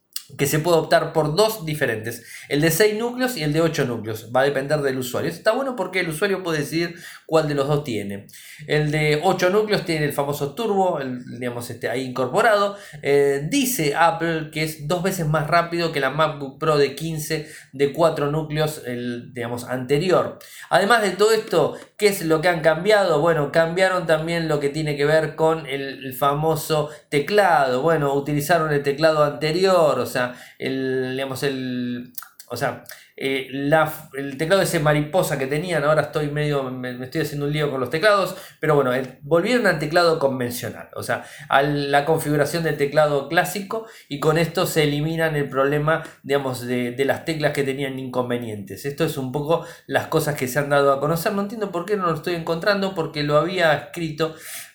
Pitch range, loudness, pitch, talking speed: 140-165 Hz, -21 LUFS, 150 Hz, 195 wpm